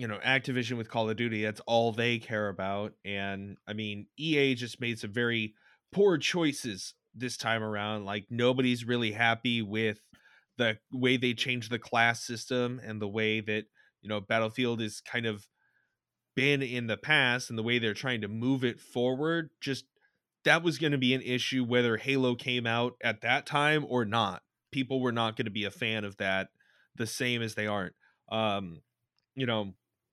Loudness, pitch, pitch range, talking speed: -30 LUFS, 120 Hz, 110-130 Hz, 190 wpm